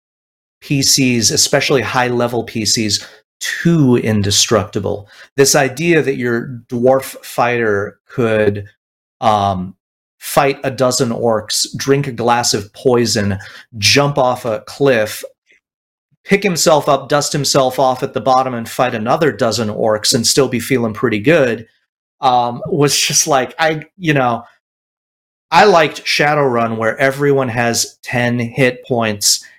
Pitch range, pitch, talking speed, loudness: 115-140 Hz, 125 Hz, 130 wpm, -14 LUFS